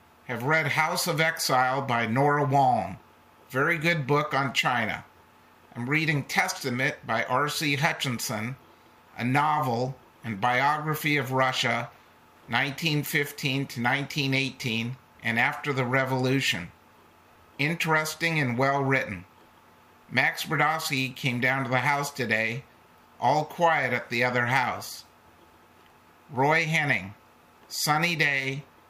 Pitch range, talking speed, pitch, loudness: 115-145 Hz, 110 wpm, 130 Hz, -26 LUFS